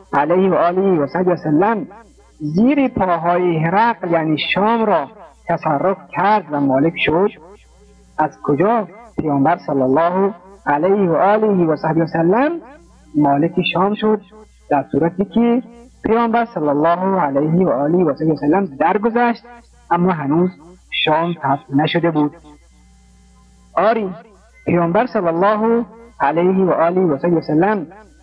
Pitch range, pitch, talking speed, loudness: 155-210 Hz, 175 Hz, 135 wpm, -17 LUFS